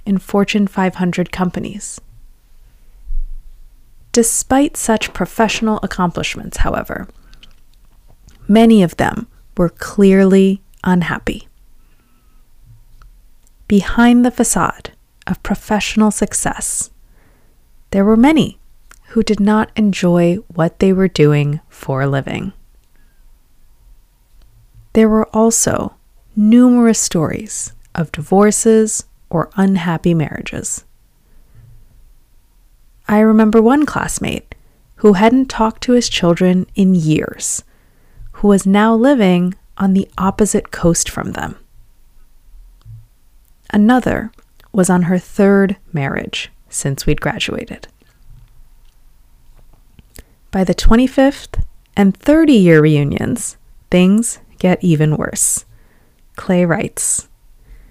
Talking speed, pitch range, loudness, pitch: 90 wpm, 140-215 Hz, -14 LUFS, 185 Hz